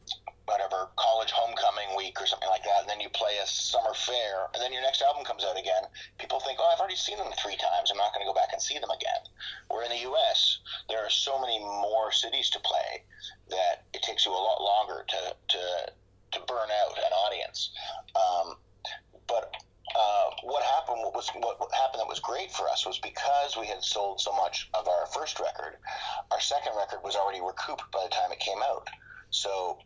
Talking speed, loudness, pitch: 215 wpm, -29 LUFS, 345 Hz